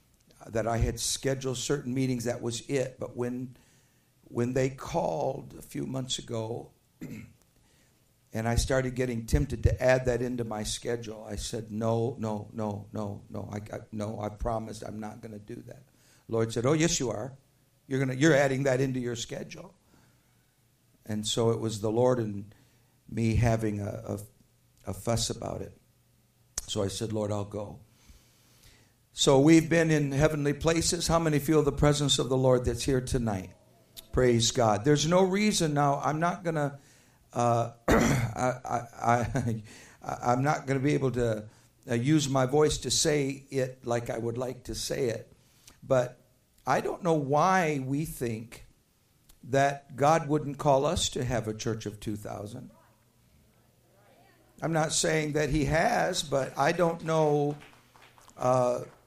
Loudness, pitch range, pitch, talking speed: -28 LUFS, 115-140 Hz, 125 Hz, 170 wpm